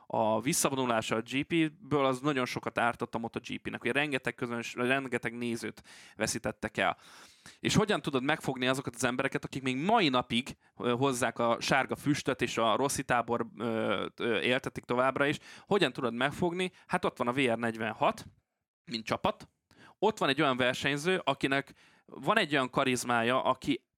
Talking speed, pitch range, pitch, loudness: 160 wpm, 120-145 Hz, 130 Hz, -31 LUFS